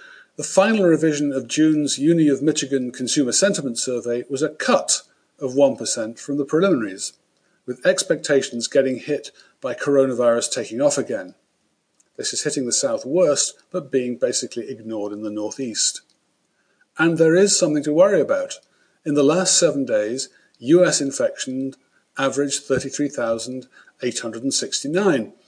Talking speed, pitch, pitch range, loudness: 135 wpm, 140 Hz, 125-165 Hz, -20 LUFS